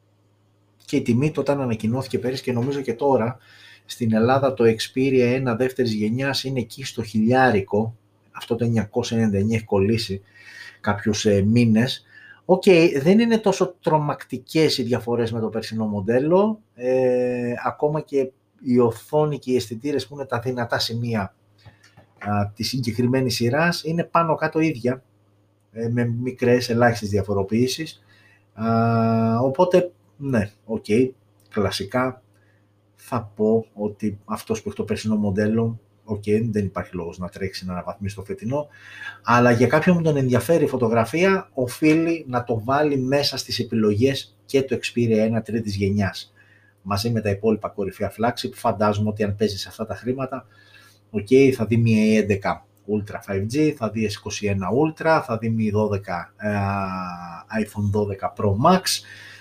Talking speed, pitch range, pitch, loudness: 150 wpm, 105-130 Hz, 115 Hz, -22 LUFS